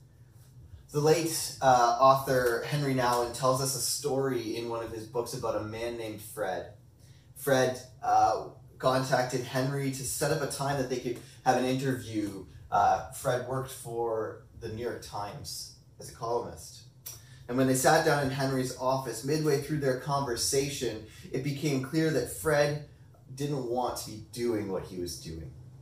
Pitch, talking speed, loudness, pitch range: 130 Hz, 165 wpm, -30 LUFS, 120-135 Hz